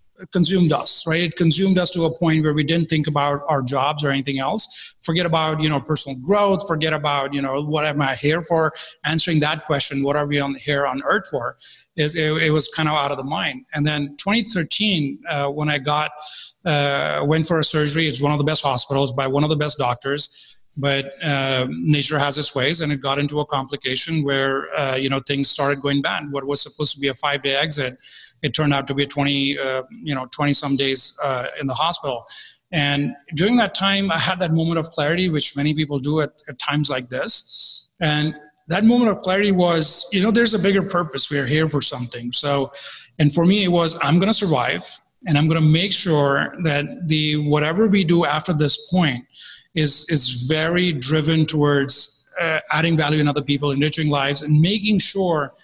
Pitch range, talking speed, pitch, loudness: 140-165 Hz, 215 wpm, 150 Hz, -19 LUFS